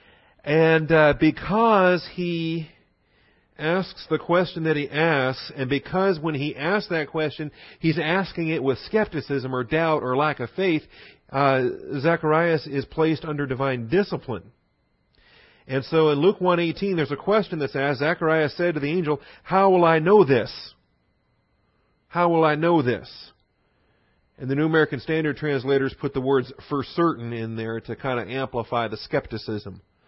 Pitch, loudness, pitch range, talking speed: 155 Hz, -23 LUFS, 135-165 Hz, 160 wpm